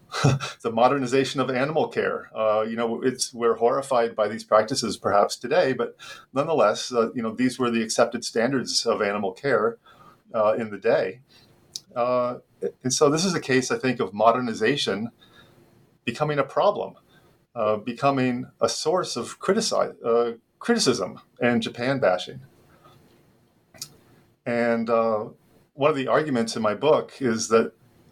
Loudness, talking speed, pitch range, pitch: -24 LUFS, 145 wpm, 115-130 Hz, 120 Hz